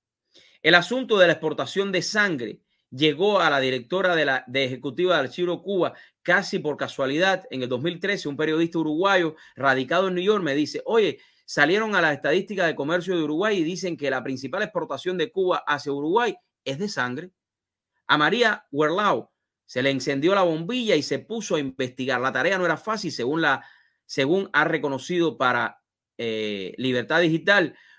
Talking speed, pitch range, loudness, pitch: 175 wpm, 135-185 Hz, -23 LUFS, 160 Hz